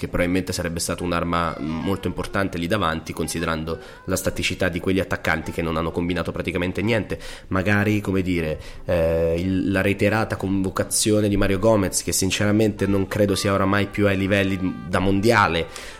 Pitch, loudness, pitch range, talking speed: 95 Hz, -22 LUFS, 85-100 Hz, 160 wpm